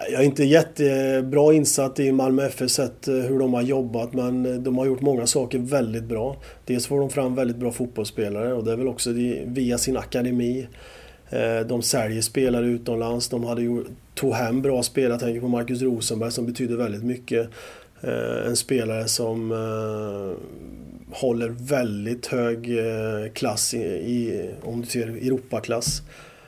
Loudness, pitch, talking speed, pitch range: -24 LUFS, 125 Hz, 150 wpm, 115-130 Hz